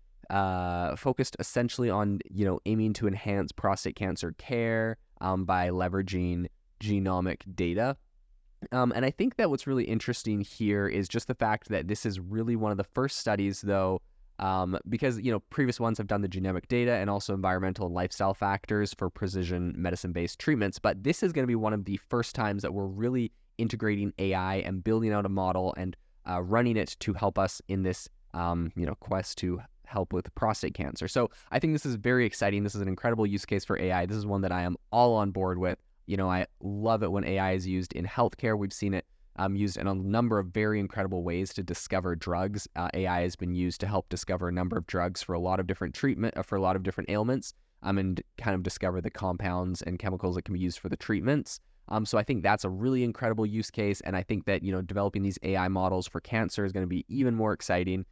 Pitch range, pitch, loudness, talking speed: 90-110 Hz, 100 Hz, -30 LUFS, 230 wpm